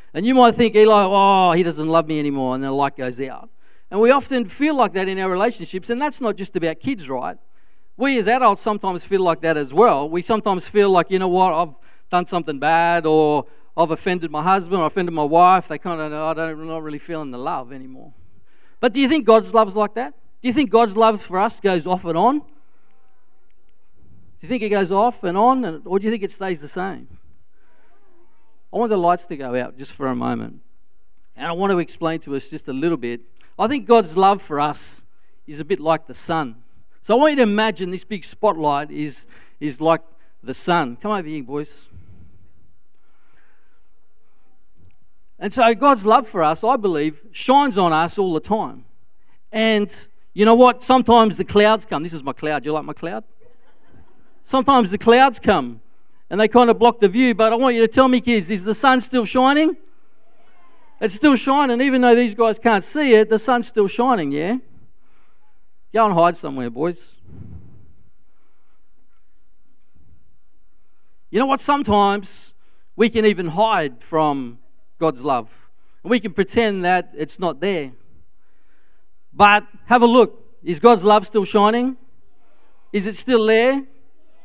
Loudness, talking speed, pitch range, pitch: -18 LUFS, 190 wpm, 160-235 Hz, 200 Hz